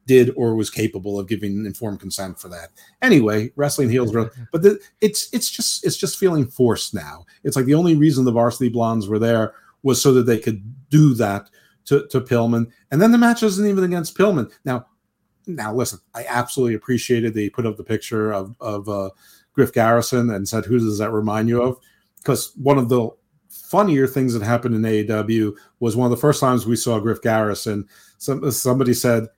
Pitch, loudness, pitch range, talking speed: 120 Hz, -19 LUFS, 110-135 Hz, 200 wpm